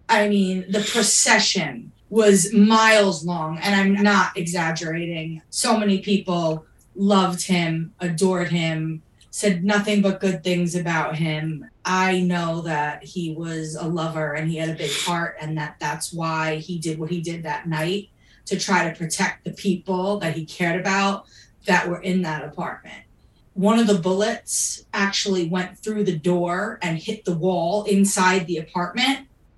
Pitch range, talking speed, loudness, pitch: 165-195 Hz, 160 wpm, -21 LUFS, 180 Hz